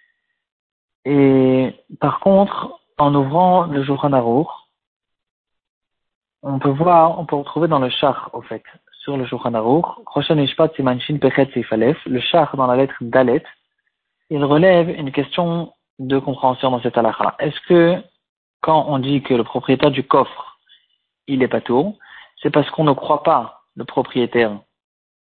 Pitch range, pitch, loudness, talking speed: 130-160 Hz, 140 Hz, -17 LUFS, 140 wpm